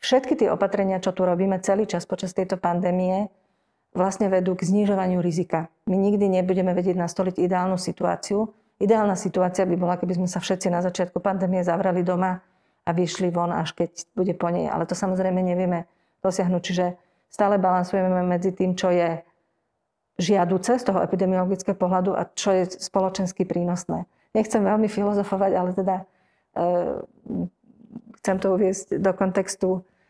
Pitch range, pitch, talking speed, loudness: 180-195 Hz, 185 Hz, 155 wpm, -24 LUFS